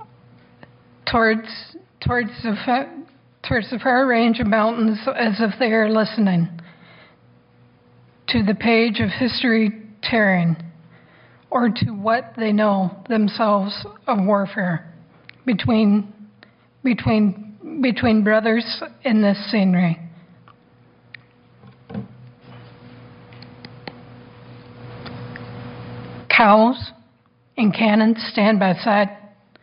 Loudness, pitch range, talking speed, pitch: -19 LUFS, 190-230 Hz, 85 wpm, 215 Hz